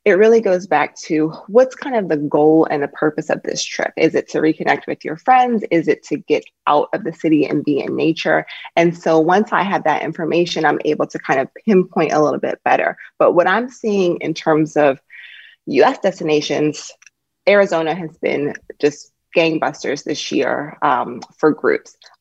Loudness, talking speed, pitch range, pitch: -17 LUFS, 190 wpm, 155-195 Hz, 165 Hz